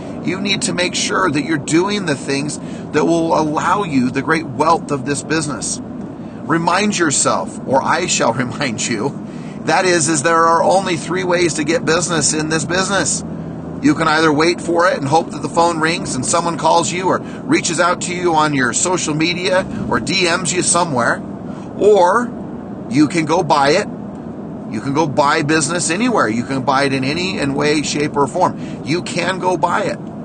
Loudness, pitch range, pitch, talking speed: -16 LUFS, 150-180 Hz, 165 Hz, 195 wpm